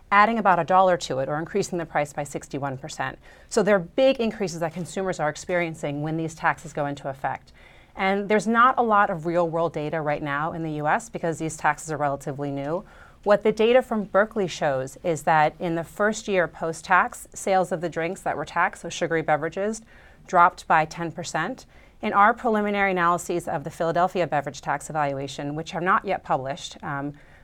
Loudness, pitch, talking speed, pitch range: -24 LUFS, 170 Hz, 195 wpm, 150-195 Hz